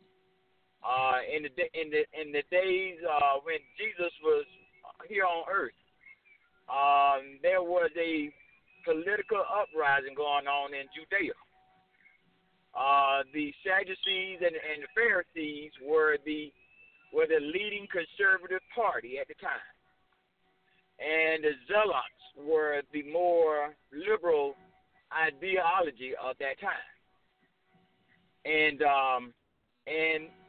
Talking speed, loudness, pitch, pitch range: 110 wpm, -30 LUFS, 160 Hz, 145-190 Hz